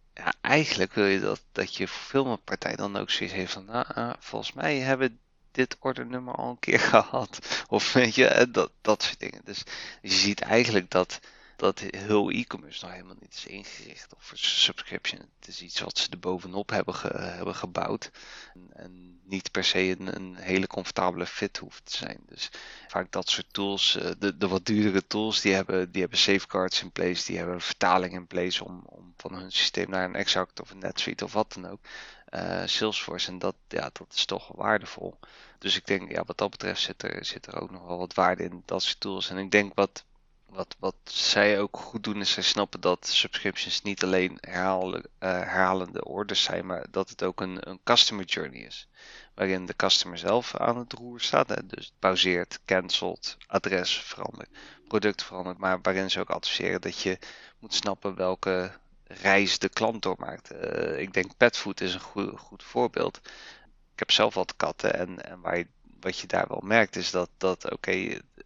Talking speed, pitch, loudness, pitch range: 200 wpm, 95 Hz, -27 LUFS, 90-105 Hz